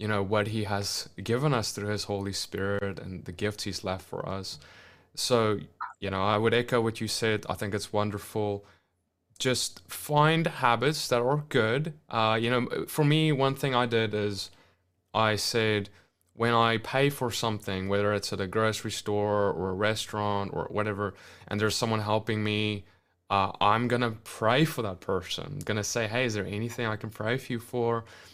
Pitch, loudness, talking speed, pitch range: 105 Hz, -28 LUFS, 195 wpm, 100-120 Hz